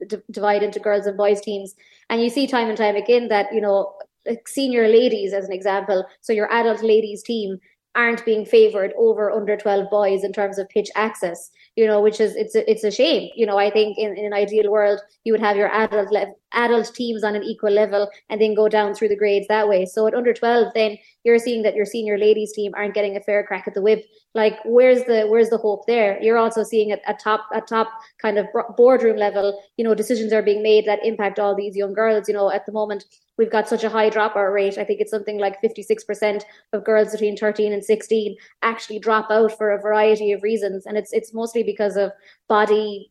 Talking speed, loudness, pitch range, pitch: 235 wpm, -20 LUFS, 205-225 Hz, 215 Hz